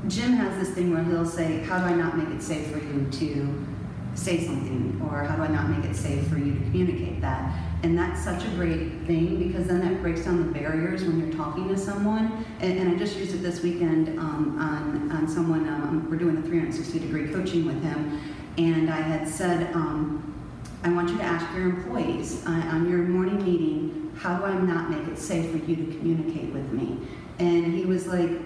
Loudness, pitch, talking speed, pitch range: -27 LUFS, 165 Hz, 220 wpm, 150-175 Hz